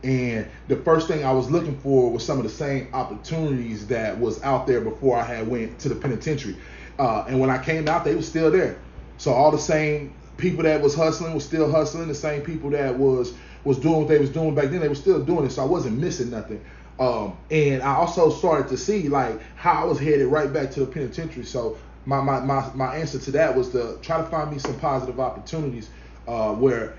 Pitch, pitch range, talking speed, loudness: 140 Hz, 125-155 Hz, 235 wpm, -23 LUFS